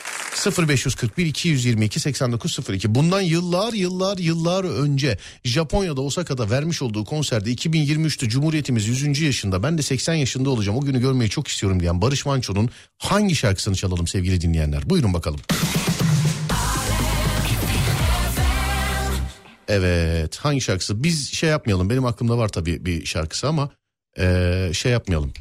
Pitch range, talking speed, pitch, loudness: 95-155 Hz, 125 wpm, 125 Hz, -21 LUFS